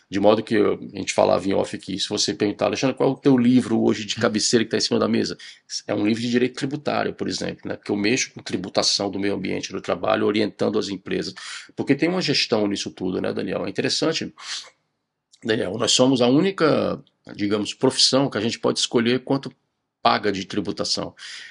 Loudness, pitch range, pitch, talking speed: -22 LUFS, 105-130 Hz, 115 Hz, 210 wpm